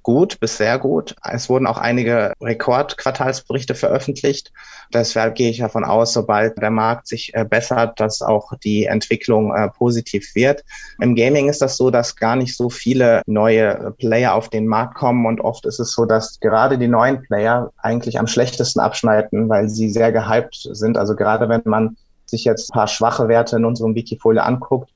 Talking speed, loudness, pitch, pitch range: 180 wpm, -17 LUFS, 115 Hz, 110-120 Hz